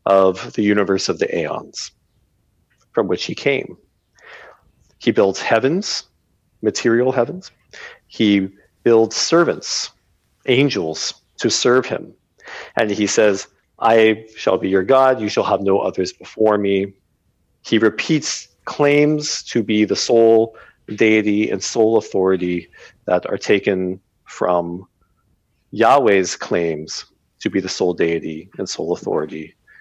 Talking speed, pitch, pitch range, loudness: 125 wpm, 105 Hz, 90-115 Hz, -18 LUFS